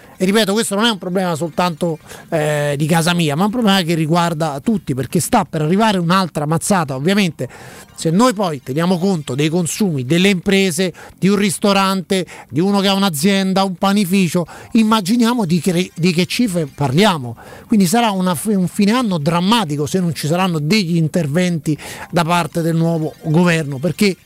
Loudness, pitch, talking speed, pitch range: -16 LUFS, 180 Hz, 175 wpm, 165-200 Hz